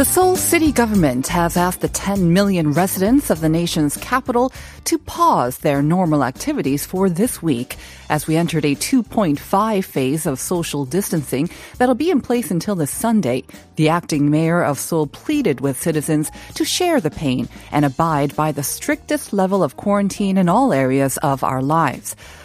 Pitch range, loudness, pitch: 145-205 Hz, -18 LUFS, 165 Hz